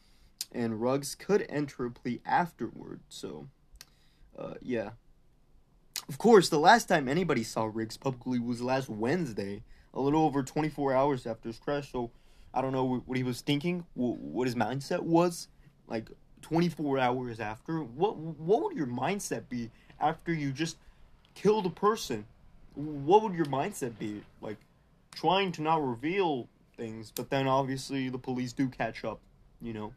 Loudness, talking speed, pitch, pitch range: -31 LUFS, 160 wpm, 135 Hz, 120-155 Hz